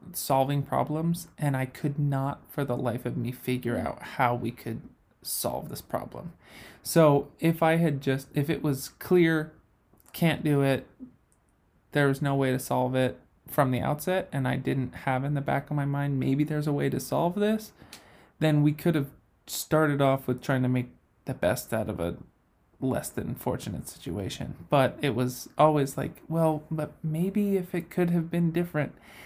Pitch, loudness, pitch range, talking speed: 145 Hz, -28 LUFS, 130-160 Hz, 185 wpm